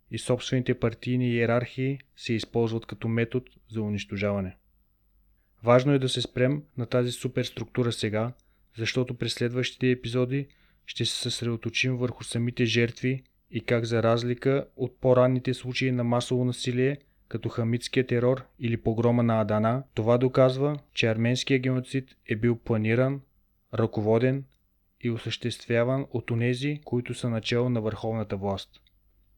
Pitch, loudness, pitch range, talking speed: 120 Hz, -27 LUFS, 115-125 Hz, 135 wpm